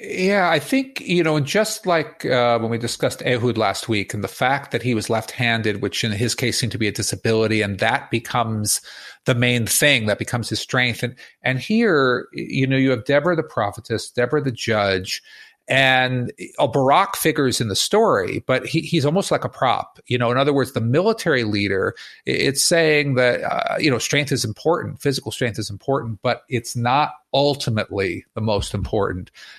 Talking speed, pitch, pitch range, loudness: 195 wpm, 125 Hz, 115-140 Hz, -20 LUFS